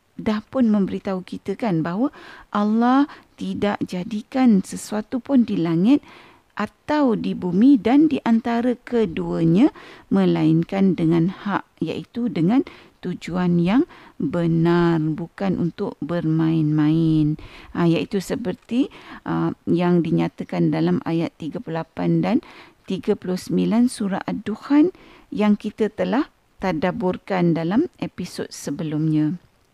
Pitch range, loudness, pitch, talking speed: 165-245 Hz, -21 LUFS, 195 Hz, 105 wpm